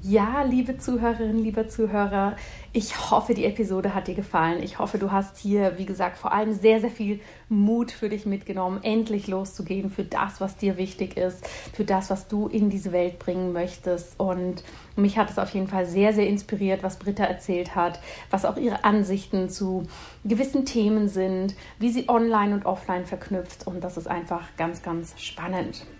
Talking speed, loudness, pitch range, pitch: 185 wpm, -26 LUFS, 185-215 Hz, 195 Hz